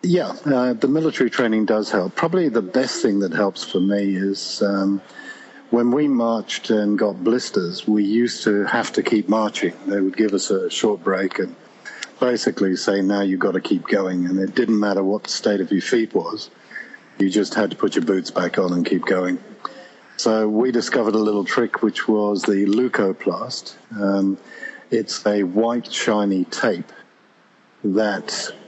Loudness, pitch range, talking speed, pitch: -20 LUFS, 100-115 Hz, 180 wpm, 105 Hz